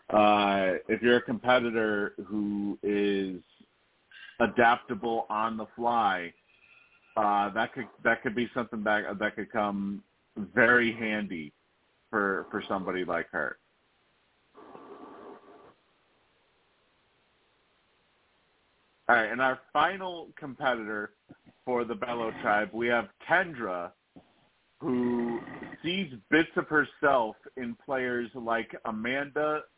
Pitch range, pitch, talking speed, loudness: 105-125 Hz, 115 Hz, 105 wpm, -29 LUFS